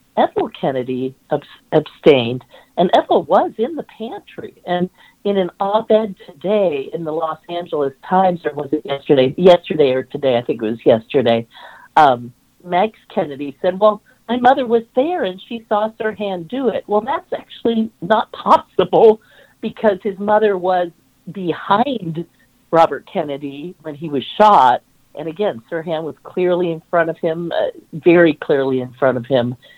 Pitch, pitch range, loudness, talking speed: 180 Hz, 150-215 Hz, -17 LUFS, 160 wpm